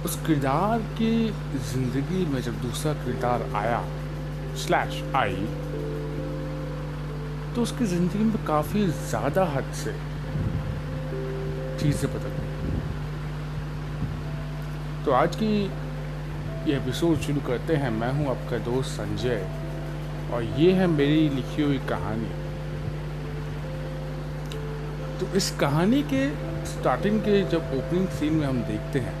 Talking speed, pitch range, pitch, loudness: 115 wpm, 120-155 Hz, 150 Hz, -27 LUFS